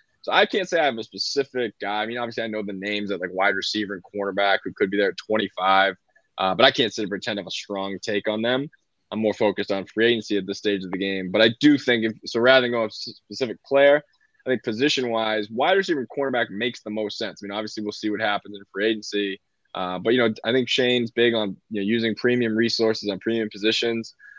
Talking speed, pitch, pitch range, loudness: 255 wpm, 110 Hz, 100-120 Hz, -23 LUFS